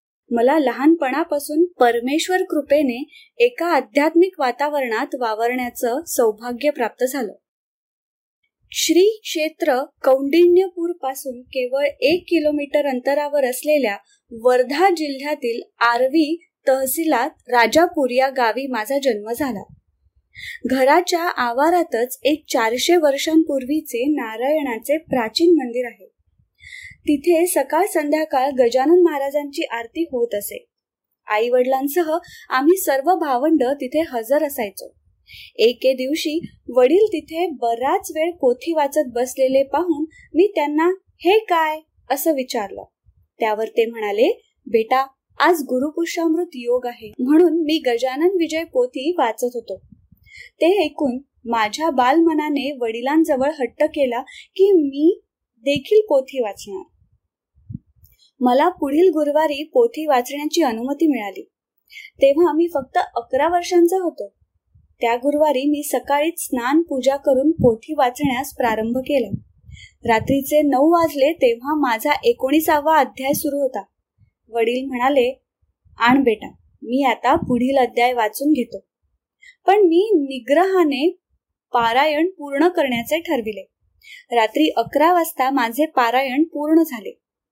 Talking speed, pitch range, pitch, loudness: 105 wpm, 255-330 Hz, 290 Hz, -19 LUFS